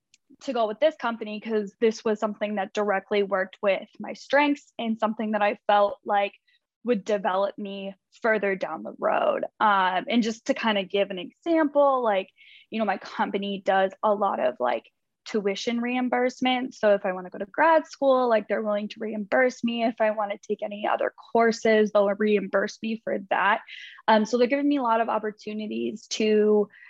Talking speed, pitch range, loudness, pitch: 195 wpm, 205-240 Hz, -25 LUFS, 215 Hz